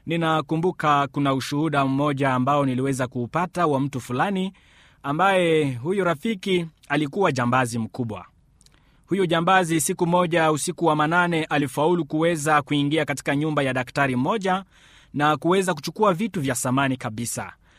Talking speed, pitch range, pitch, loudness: 130 wpm, 135-175 Hz, 150 Hz, -22 LUFS